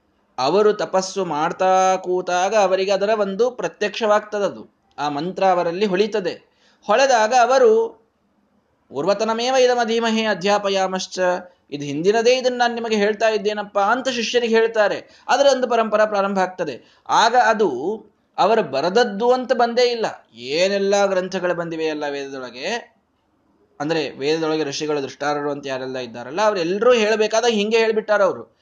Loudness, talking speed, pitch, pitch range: -19 LUFS, 120 wpm, 205 Hz, 180-225 Hz